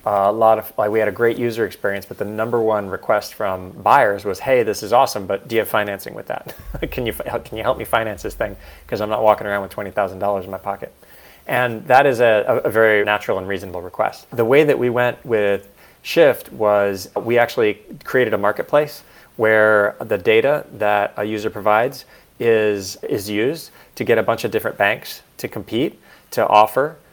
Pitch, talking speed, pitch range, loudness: 105 Hz, 210 wpm, 100-115 Hz, -18 LUFS